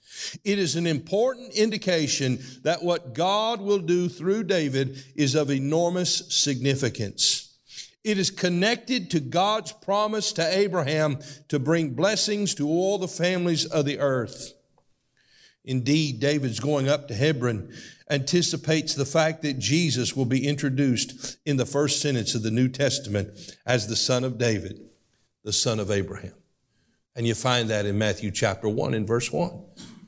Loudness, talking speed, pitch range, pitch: -24 LUFS, 150 wpm, 125-175 Hz, 145 Hz